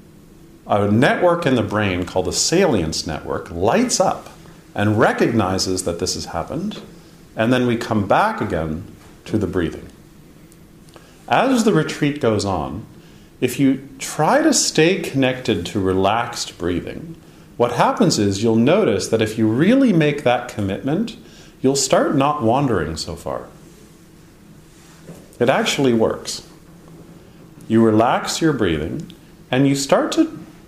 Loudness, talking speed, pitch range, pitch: -18 LUFS, 135 wpm, 105-165 Hz, 125 Hz